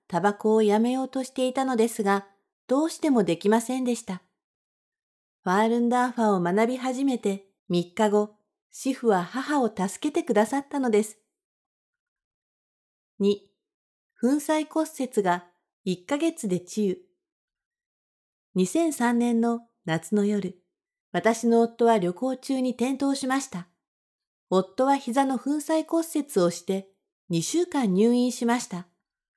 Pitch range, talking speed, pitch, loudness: 200-275 Hz, 225 characters per minute, 235 Hz, -25 LUFS